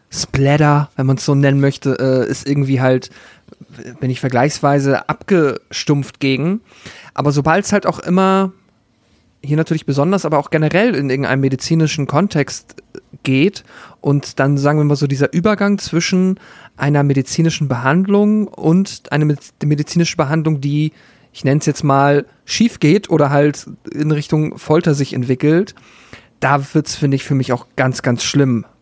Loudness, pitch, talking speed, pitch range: -16 LUFS, 145 Hz, 155 wpm, 135-160 Hz